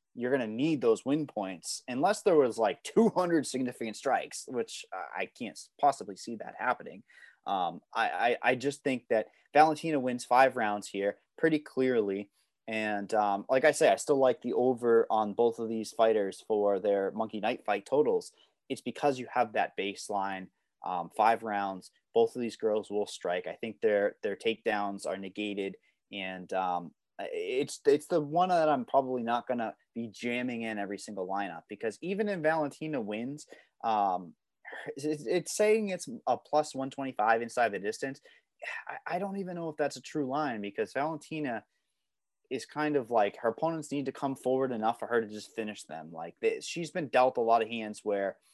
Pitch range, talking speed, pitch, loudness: 105-155 Hz, 185 wpm, 125 Hz, -31 LUFS